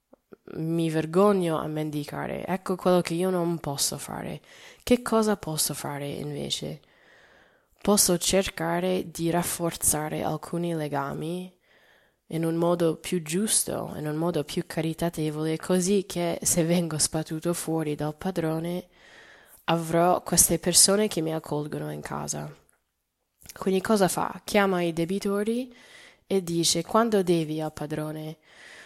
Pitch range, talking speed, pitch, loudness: 155-185 Hz, 125 wpm, 170 Hz, -26 LUFS